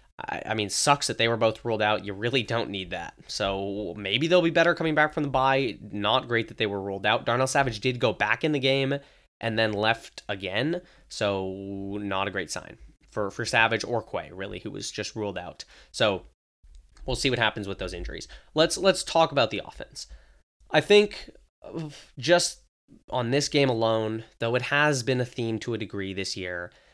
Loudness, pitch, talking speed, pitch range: -26 LUFS, 115 Hz, 205 wpm, 100-140 Hz